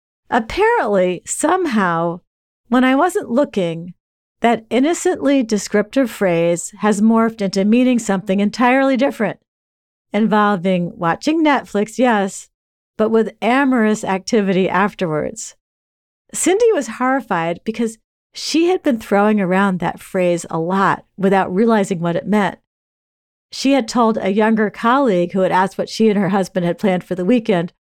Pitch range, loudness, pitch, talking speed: 185-245 Hz, -17 LUFS, 210 Hz, 135 wpm